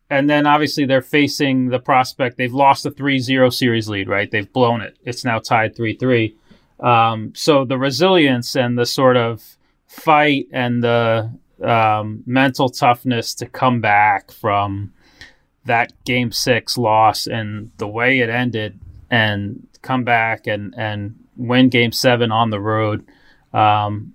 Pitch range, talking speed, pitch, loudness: 110-130 Hz, 150 wpm, 120 Hz, -17 LUFS